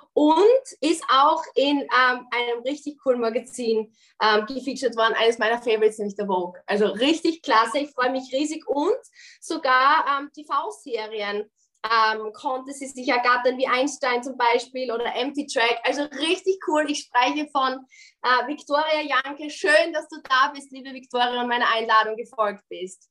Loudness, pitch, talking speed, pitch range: -22 LUFS, 255 Hz, 160 wpm, 230-290 Hz